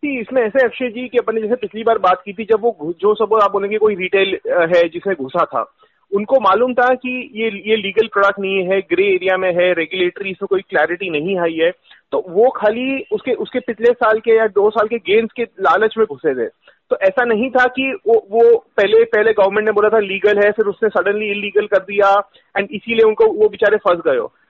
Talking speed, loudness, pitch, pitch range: 225 wpm, -16 LUFS, 220 Hz, 200-250 Hz